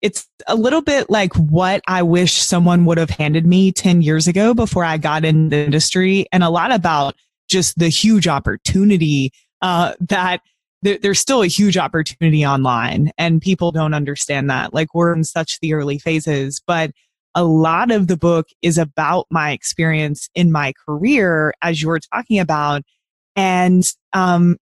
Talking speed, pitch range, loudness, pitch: 170 wpm, 155-185 Hz, -16 LUFS, 170 Hz